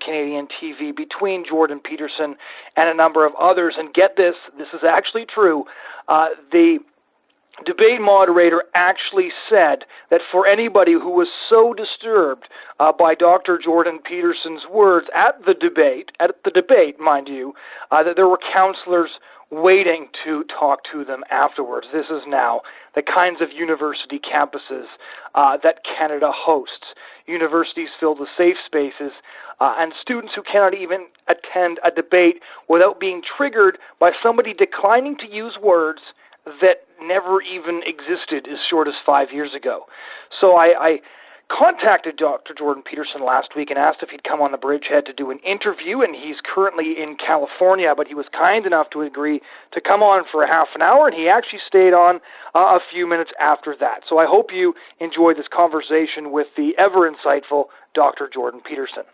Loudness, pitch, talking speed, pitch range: -17 LUFS, 170 Hz, 170 wpm, 150-195 Hz